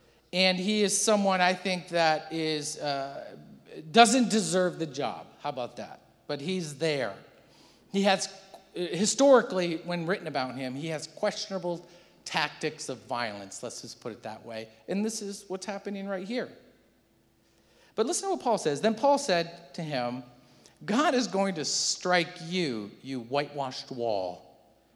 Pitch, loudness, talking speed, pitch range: 175 Hz, -28 LUFS, 155 wpm, 140-195 Hz